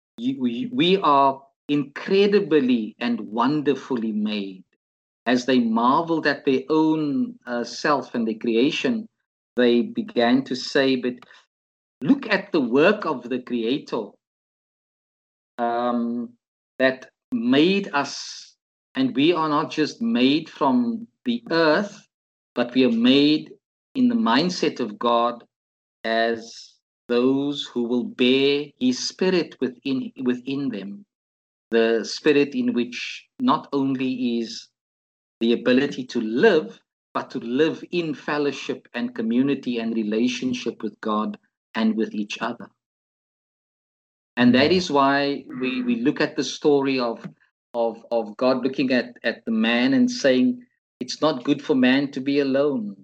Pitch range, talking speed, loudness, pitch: 120-155 Hz, 130 wpm, -22 LUFS, 135 Hz